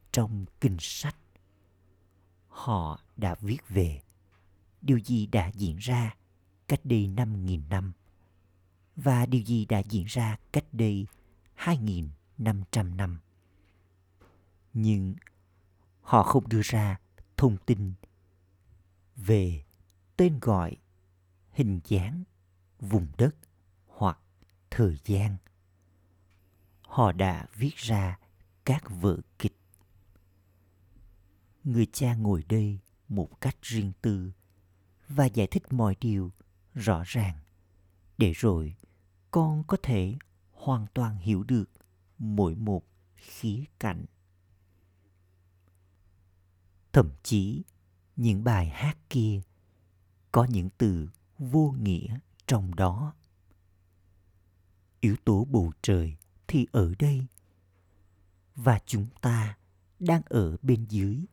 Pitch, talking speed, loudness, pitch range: 95 Hz, 105 wpm, -29 LUFS, 90-110 Hz